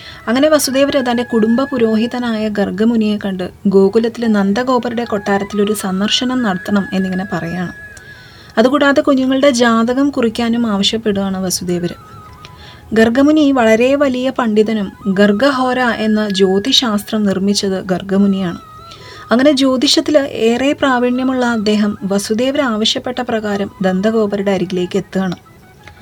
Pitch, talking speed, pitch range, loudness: 220 Hz, 90 wpm, 200-255 Hz, -14 LUFS